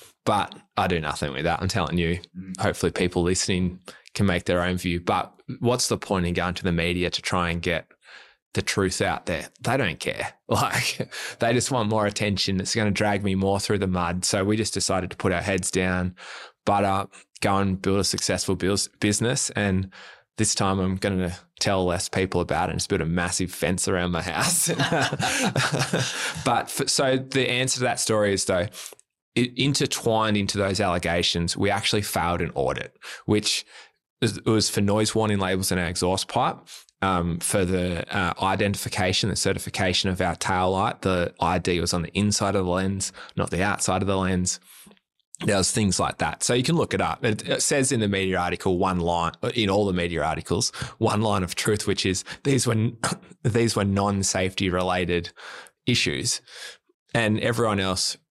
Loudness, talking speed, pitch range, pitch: -24 LUFS, 190 wpm, 90-110 Hz, 95 Hz